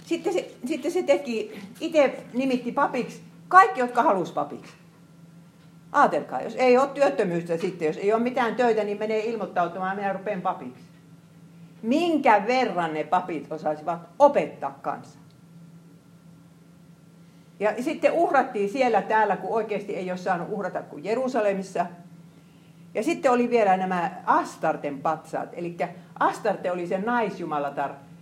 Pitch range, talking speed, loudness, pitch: 170-235 Hz, 130 wpm, -25 LUFS, 185 Hz